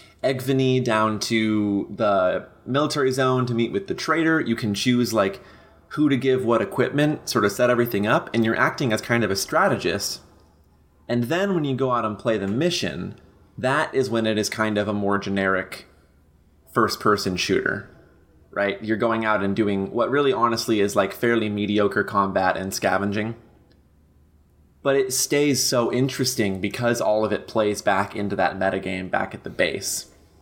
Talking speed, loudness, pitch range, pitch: 180 wpm, -22 LUFS, 95-130 Hz, 110 Hz